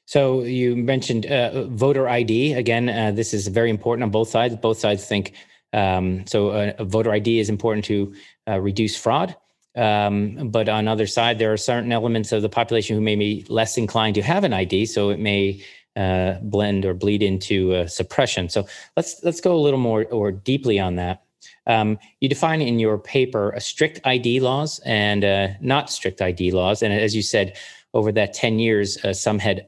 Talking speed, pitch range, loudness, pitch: 200 wpm, 100-120 Hz, -21 LUFS, 110 Hz